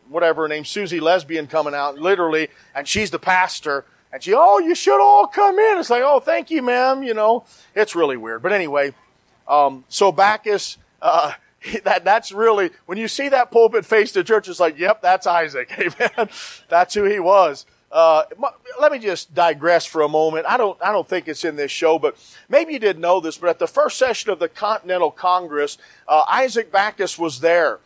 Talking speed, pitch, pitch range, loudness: 205 wpm, 185 Hz, 160-220 Hz, -18 LUFS